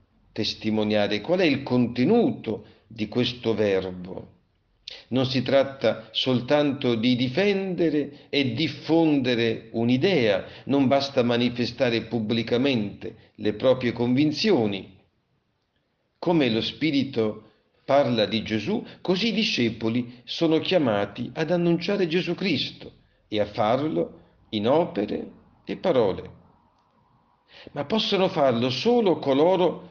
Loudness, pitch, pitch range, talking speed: -24 LUFS, 125 Hz, 110-150 Hz, 100 wpm